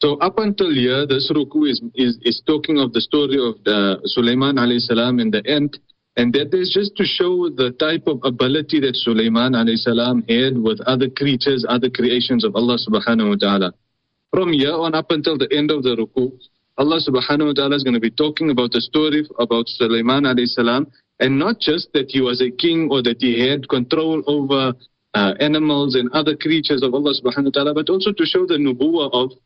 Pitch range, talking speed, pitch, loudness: 120-150 Hz, 210 wpm, 135 Hz, -18 LUFS